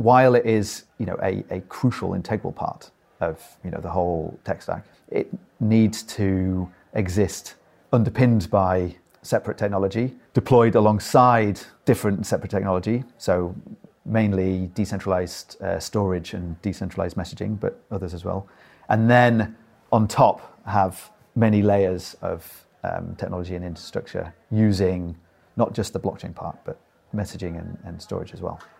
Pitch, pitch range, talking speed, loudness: 100 Hz, 90-110 Hz, 140 wpm, -23 LUFS